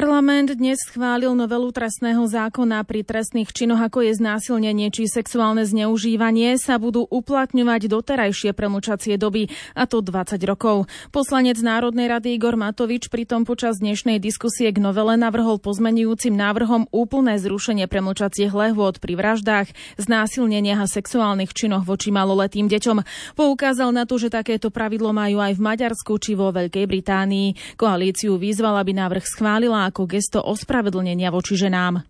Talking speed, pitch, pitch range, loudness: 140 wpm, 220 Hz, 205-235 Hz, -20 LUFS